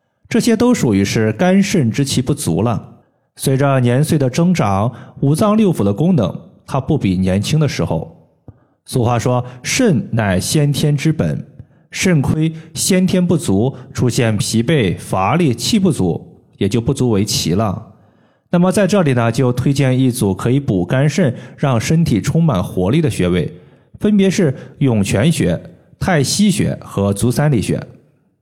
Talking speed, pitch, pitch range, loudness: 225 characters per minute, 135 Hz, 115-160 Hz, -15 LUFS